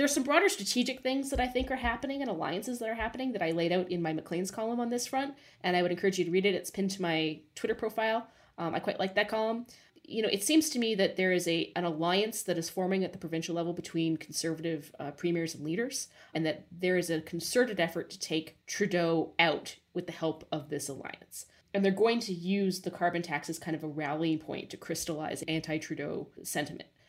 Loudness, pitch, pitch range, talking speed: -32 LUFS, 180 Hz, 165-225 Hz, 235 wpm